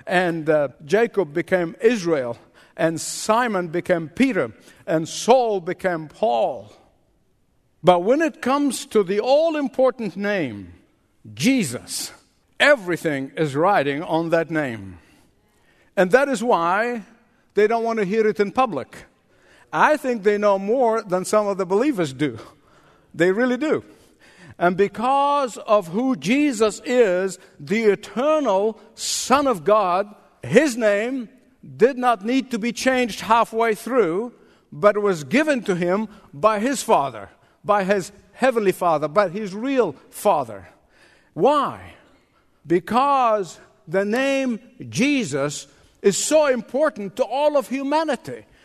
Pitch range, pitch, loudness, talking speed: 175-250 Hz, 210 Hz, -21 LUFS, 130 wpm